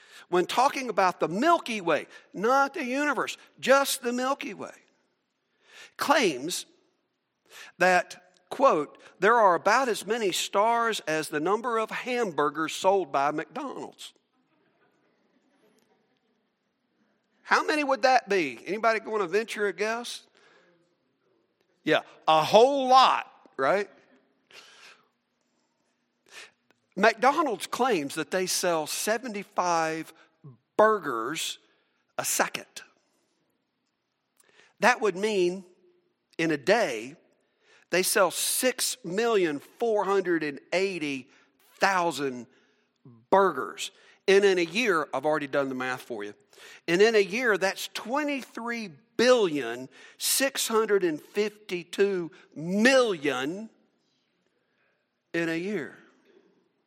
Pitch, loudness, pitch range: 200 Hz, -26 LUFS, 165-245 Hz